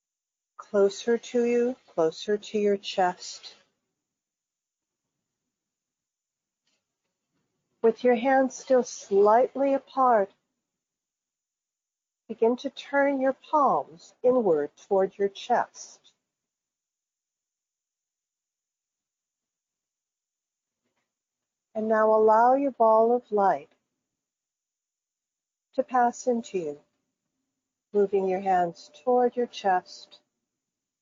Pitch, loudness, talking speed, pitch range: 225 Hz, -25 LUFS, 75 wpm, 200-255 Hz